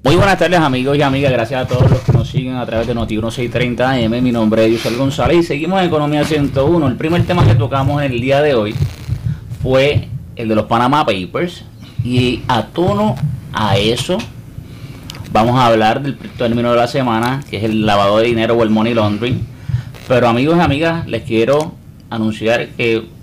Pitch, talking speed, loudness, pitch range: 125 Hz, 190 wpm, -15 LUFS, 115-140 Hz